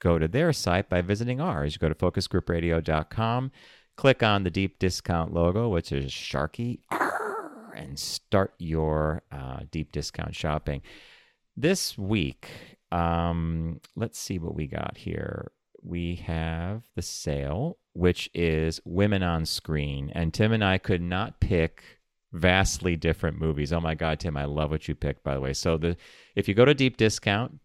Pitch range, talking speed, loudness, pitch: 80-100 Hz, 165 wpm, -27 LUFS, 85 Hz